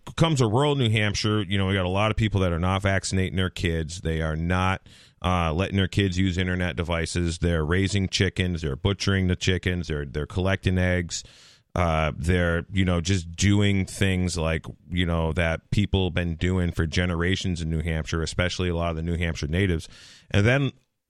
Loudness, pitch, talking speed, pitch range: -25 LUFS, 90 Hz, 195 wpm, 85-100 Hz